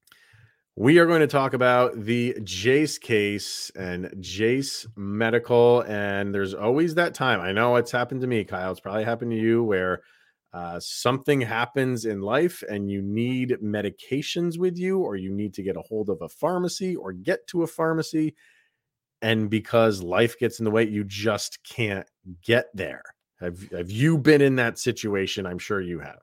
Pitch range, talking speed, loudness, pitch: 100-130 Hz, 180 wpm, -24 LUFS, 115 Hz